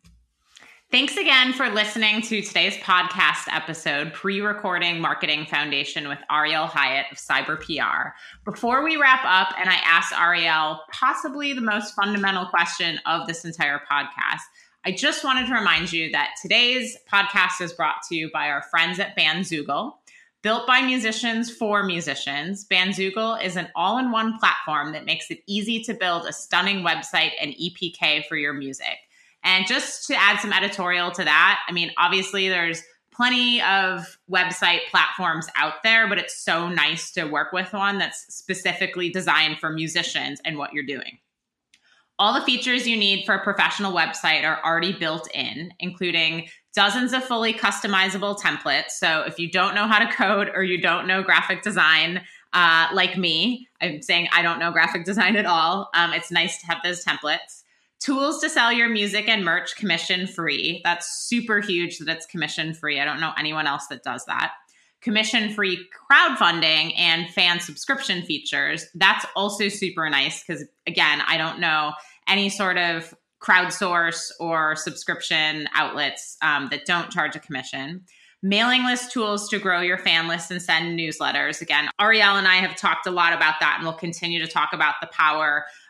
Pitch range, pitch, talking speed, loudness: 165-205 Hz, 180 Hz, 170 wpm, -21 LUFS